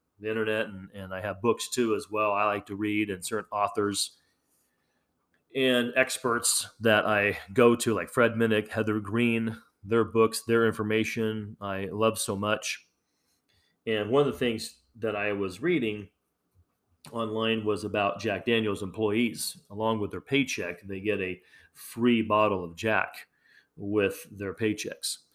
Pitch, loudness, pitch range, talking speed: 110 Hz, -28 LUFS, 100-115 Hz, 155 wpm